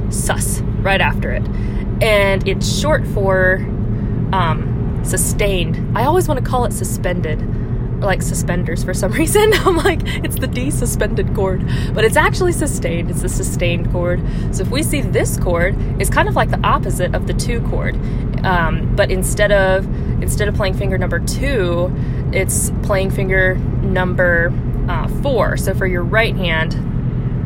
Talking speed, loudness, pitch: 165 wpm, -17 LUFS, 130 Hz